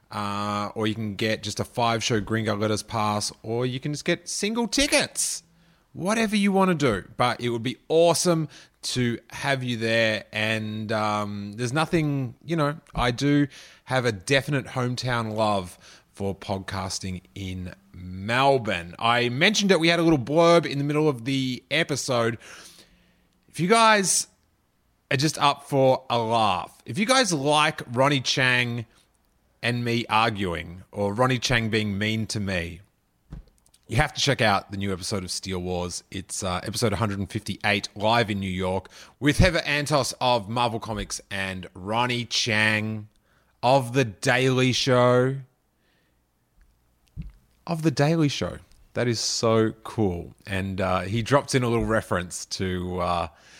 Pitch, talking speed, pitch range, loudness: 115 Hz, 155 wpm, 100-140 Hz, -24 LUFS